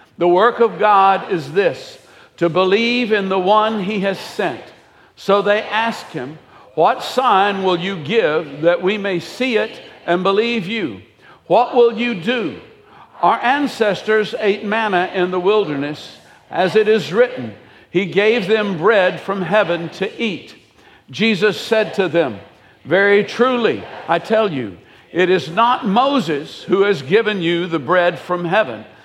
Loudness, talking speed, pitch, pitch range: -17 LUFS, 155 wpm, 200 Hz, 180-220 Hz